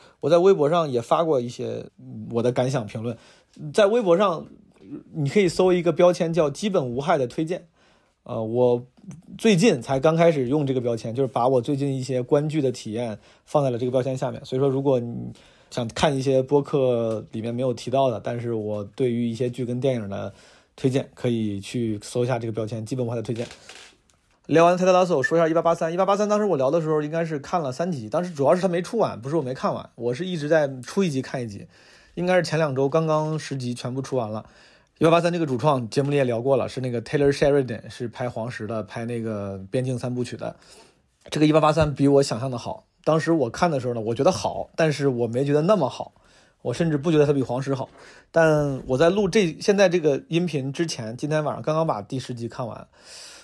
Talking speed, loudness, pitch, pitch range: 345 characters per minute, -23 LUFS, 135 Hz, 120-165 Hz